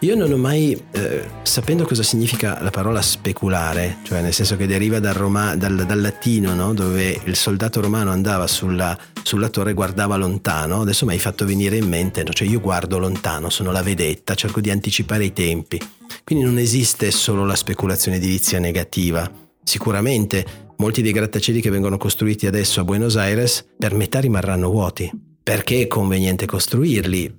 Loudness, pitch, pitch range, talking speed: -19 LUFS, 100 Hz, 95-110 Hz, 175 wpm